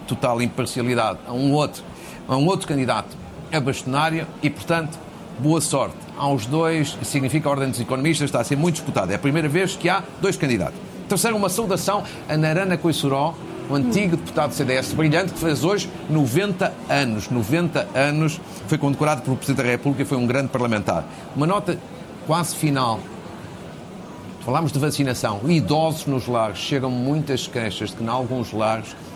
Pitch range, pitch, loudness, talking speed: 130-165 Hz, 145 Hz, -22 LUFS, 175 wpm